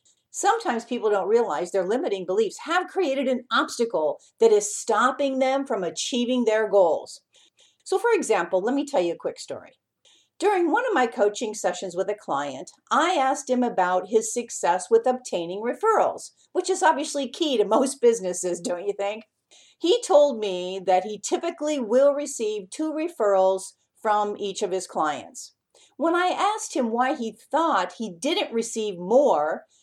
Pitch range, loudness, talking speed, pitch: 205-315 Hz, -24 LUFS, 165 wpm, 245 Hz